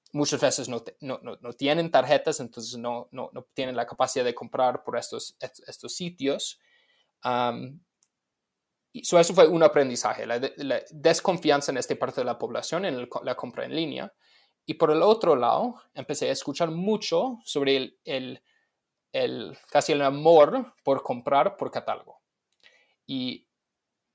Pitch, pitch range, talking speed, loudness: 150 Hz, 135-180 Hz, 160 wpm, -25 LUFS